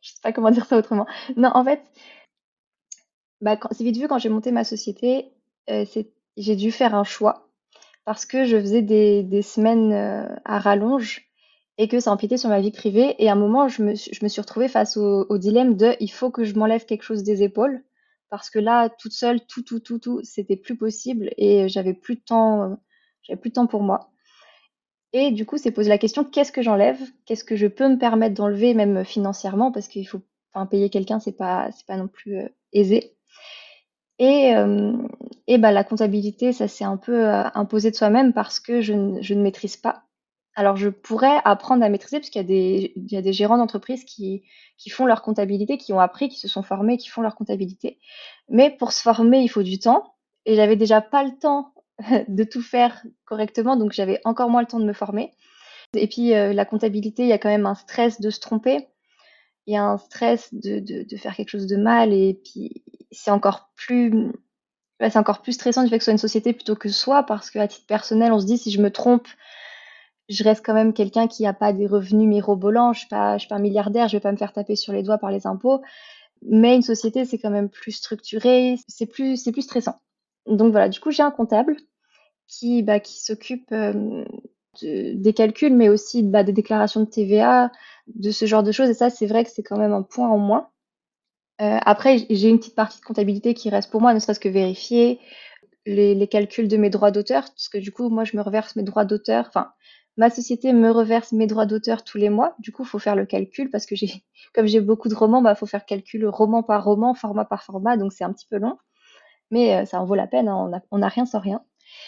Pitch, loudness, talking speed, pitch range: 220 Hz, -20 LUFS, 235 wpm, 205-245 Hz